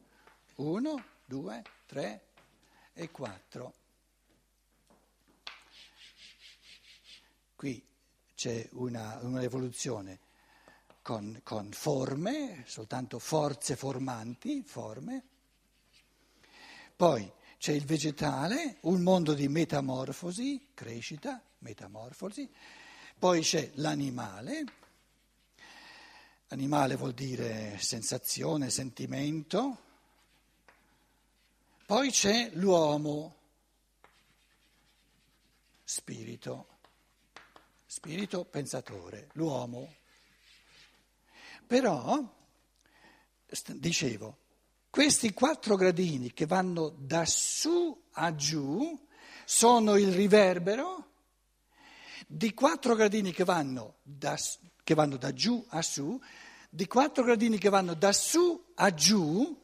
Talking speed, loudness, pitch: 80 wpm, -30 LUFS, 165 Hz